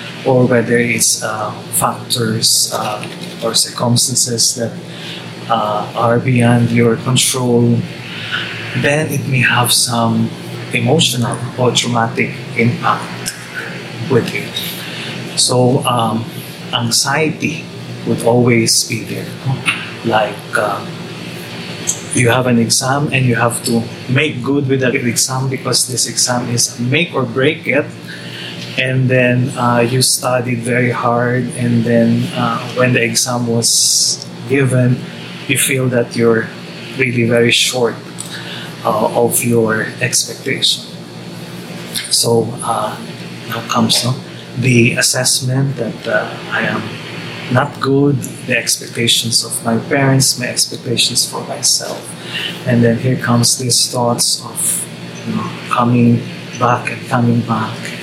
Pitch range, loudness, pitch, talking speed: 115-130 Hz, -14 LUFS, 120 Hz, 120 wpm